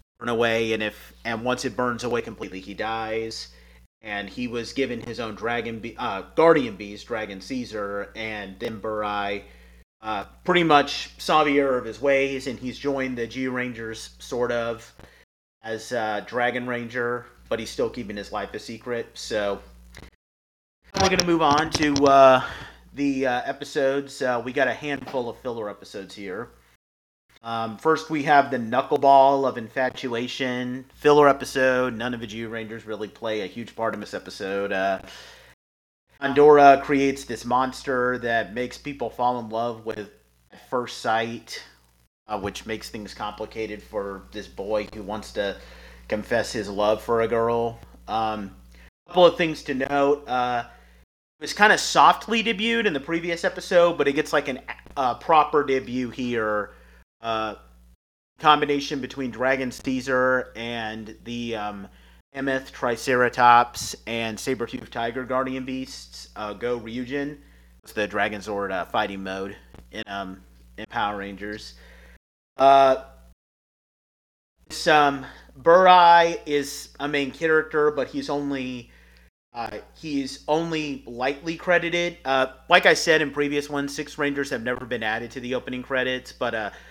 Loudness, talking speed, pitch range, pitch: -23 LUFS, 155 wpm, 105-135 Hz, 120 Hz